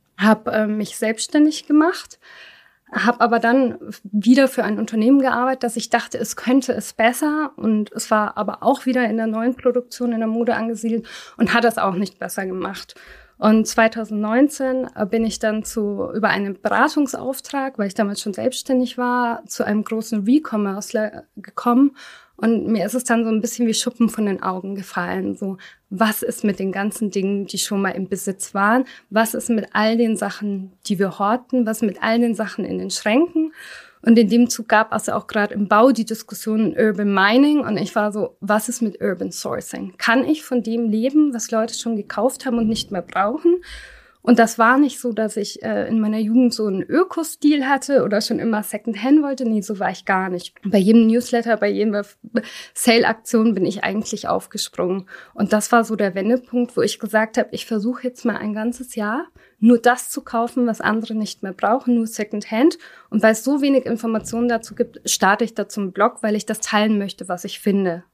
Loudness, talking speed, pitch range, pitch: -20 LUFS, 205 wpm, 210-245 Hz, 225 Hz